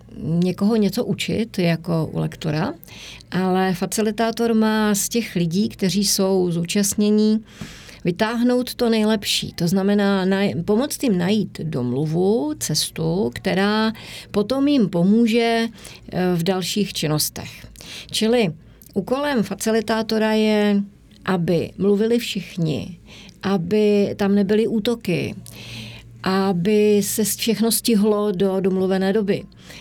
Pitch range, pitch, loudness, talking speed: 185-220 Hz, 200 Hz, -20 LUFS, 100 wpm